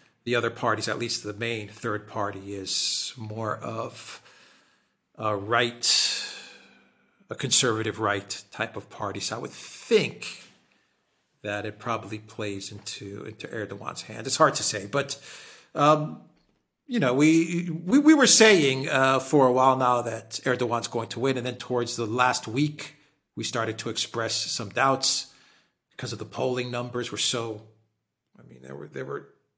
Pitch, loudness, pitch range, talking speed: 115 Hz, -25 LUFS, 110-135 Hz, 160 wpm